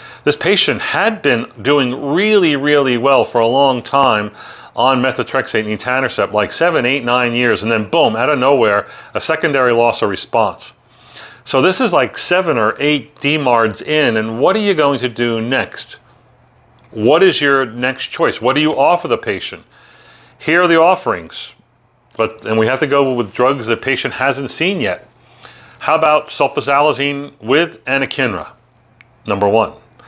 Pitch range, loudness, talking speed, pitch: 120-140 Hz, -14 LUFS, 170 wpm, 130 Hz